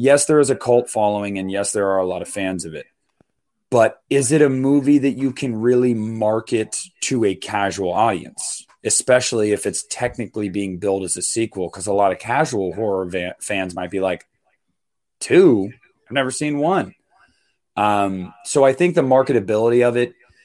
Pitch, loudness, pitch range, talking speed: 110 Hz, -19 LUFS, 95-130 Hz, 185 wpm